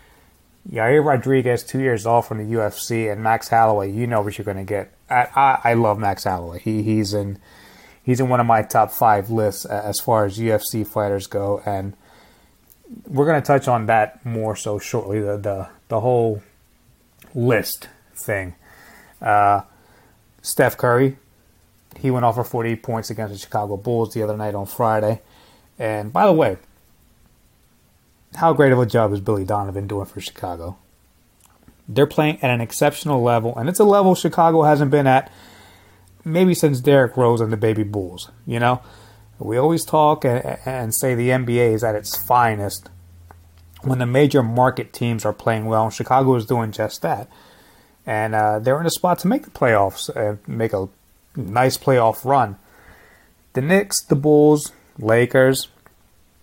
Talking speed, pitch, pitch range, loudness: 170 wpm, 115 Hz, 105-130 Hz, -19 LUFS